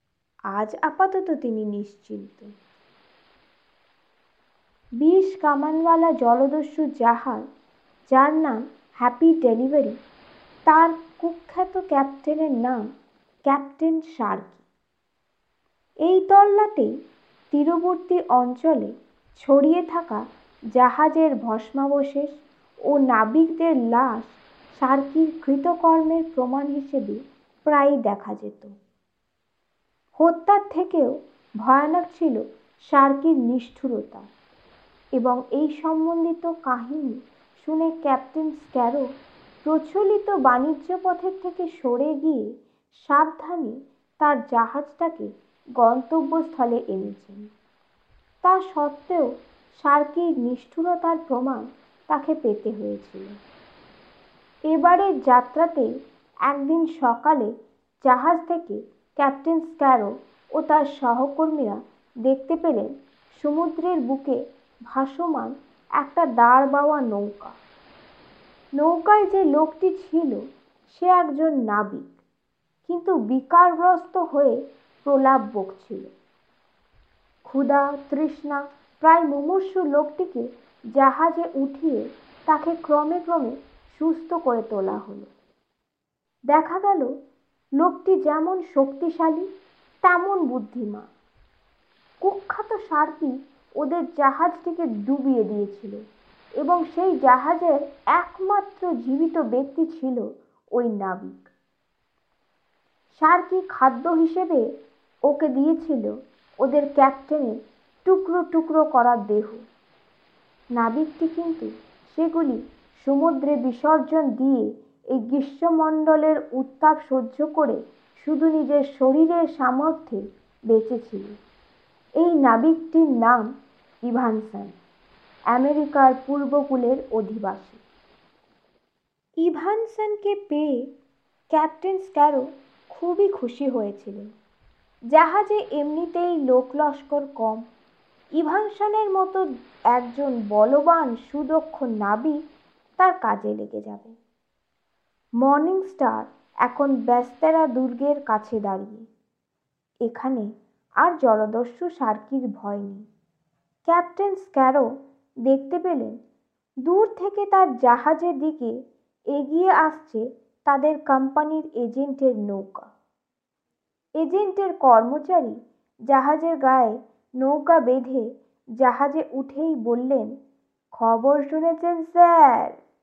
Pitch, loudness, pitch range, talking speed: 285 Hz, -22 LUFS, 250-325 Hz, 80 wpm